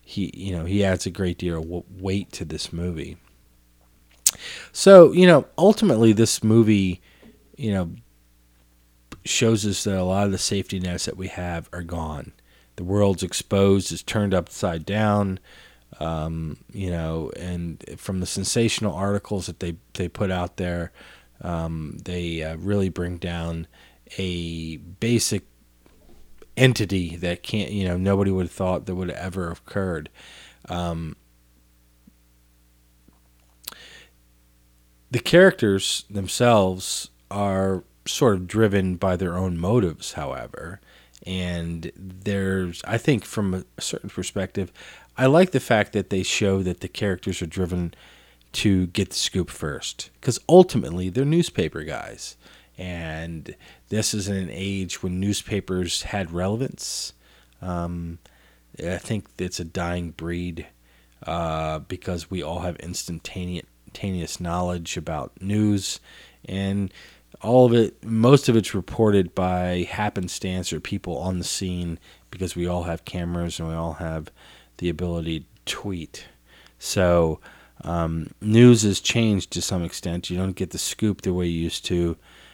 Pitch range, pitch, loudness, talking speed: 85-100 Hz, 90 Hz, -23 LUFS, 140 wpm